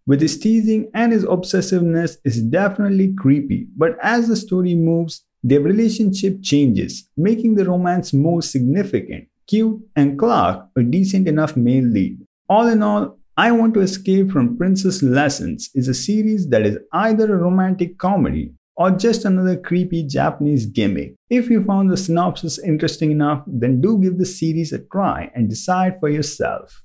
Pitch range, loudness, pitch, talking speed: 150-205 Hz, -18 LUFS, 180 Hz, 165 wpm